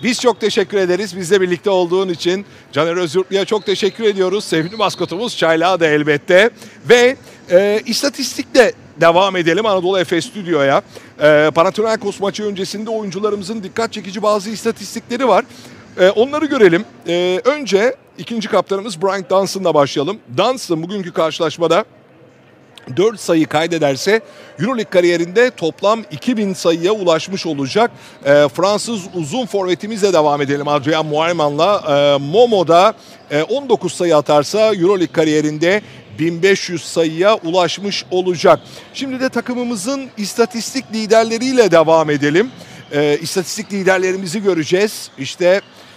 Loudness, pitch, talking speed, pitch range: -15 LUFS, 190 Hz, 120 wpm, 165-220 Hz